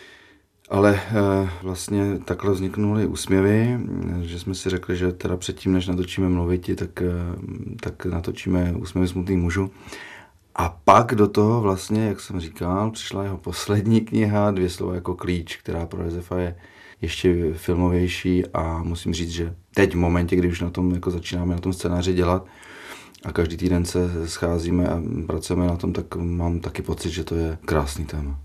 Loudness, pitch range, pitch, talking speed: -23 LUFS, 85-95 Hz, 90 Hz, 170 wpm